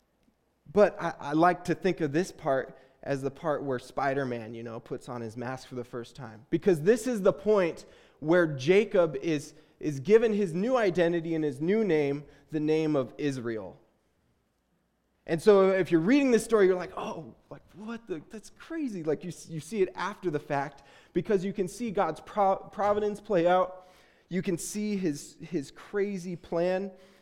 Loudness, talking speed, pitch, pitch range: -28 LUFS, 185 wpm, 175 Hz, 145-195 Hz